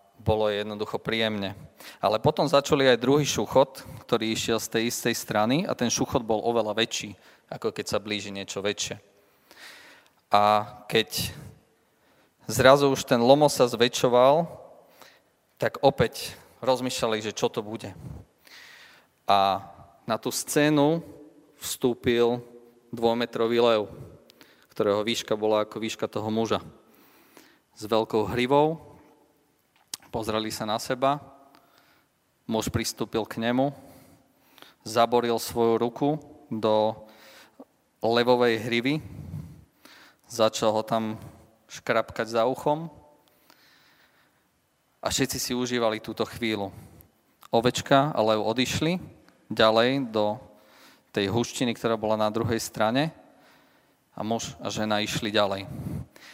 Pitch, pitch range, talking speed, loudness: 115 Hz, 110-130 Hz, 110 wpm, -25 LUFS